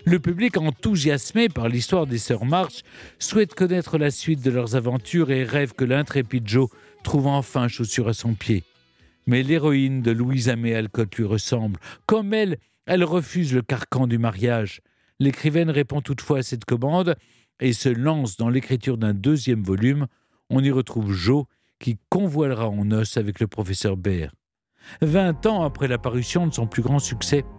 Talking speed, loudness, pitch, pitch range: 165 wpm, -23 LUFS, 130 Hz, 115-150 Hz